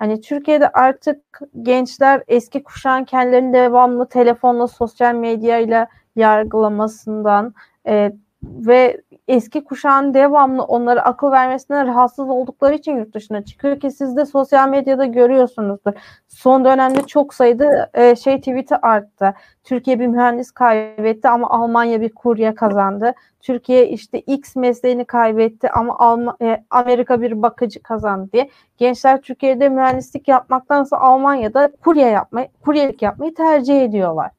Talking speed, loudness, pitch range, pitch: 120 wpm, -15 LUFS, 230-270 Hz, 250 Hz